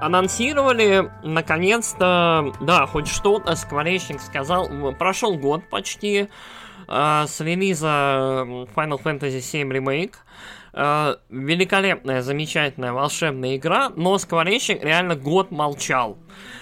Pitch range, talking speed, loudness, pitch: 140-190 Hz, 100 wpm, -21 LUFS, 160 Hz